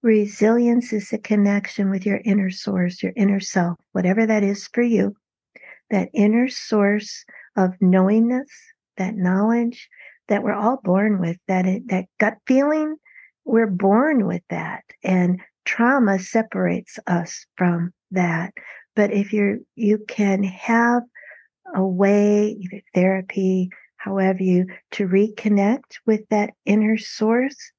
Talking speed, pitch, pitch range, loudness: 130 wpm, 205 Hz, 190-225 Hz, -20 LUFS